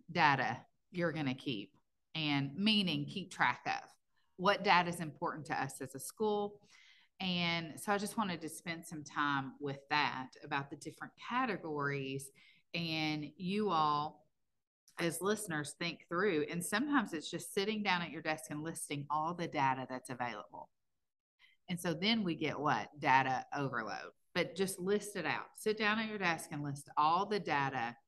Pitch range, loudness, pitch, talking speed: 145-190 Hz, -36 LUFS, 165 Hz, 170 wpm